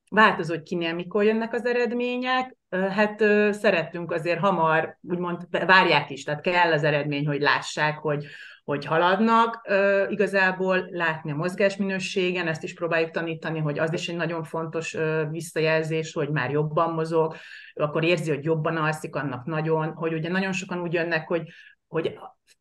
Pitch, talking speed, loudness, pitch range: 170 Hz, 150 wpm, -24 LUFS, 160-190 Hz